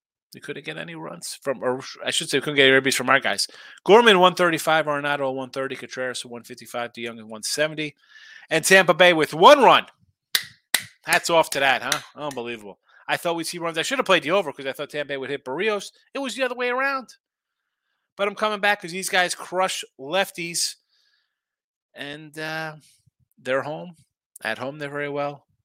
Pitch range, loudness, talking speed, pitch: 135-185 Hz, -21 LUFS, 190 wpm, 155 Hz